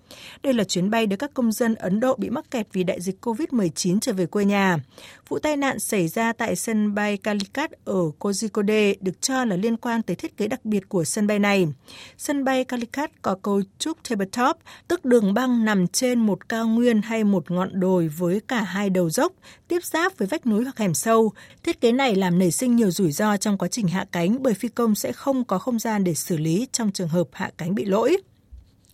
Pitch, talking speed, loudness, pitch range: 215 Hz, 230 wpm, -23 LUFS, 190-245 Hz